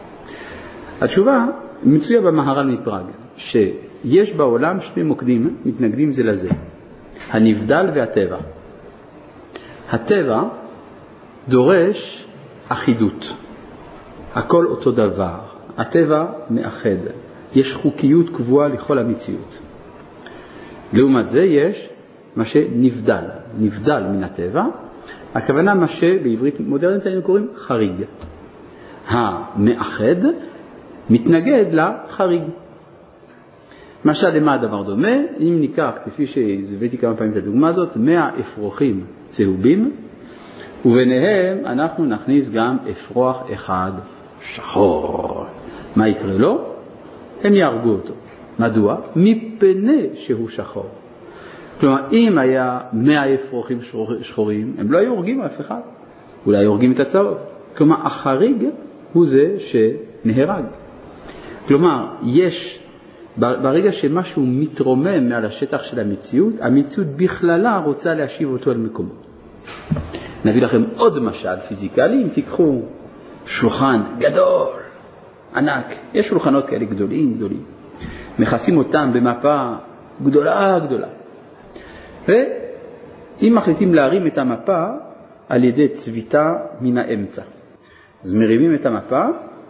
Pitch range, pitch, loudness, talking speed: 115-185 Hz, 140 Hz, -17 LUFS, 100 wpm